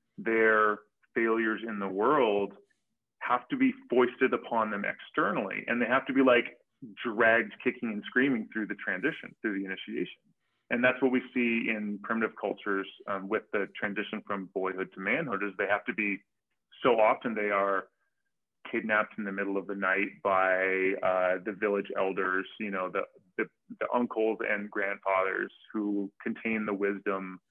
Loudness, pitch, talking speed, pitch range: -30 LUFS, 105 Hz, 170 wpm, 95-110 Hz